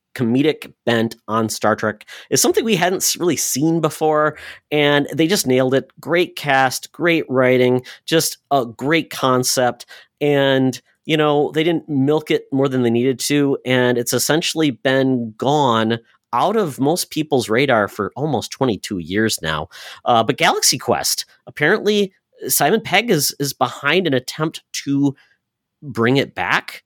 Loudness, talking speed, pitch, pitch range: -18 LUFS, 150 wpm, 140 Hz, 125-155 Hz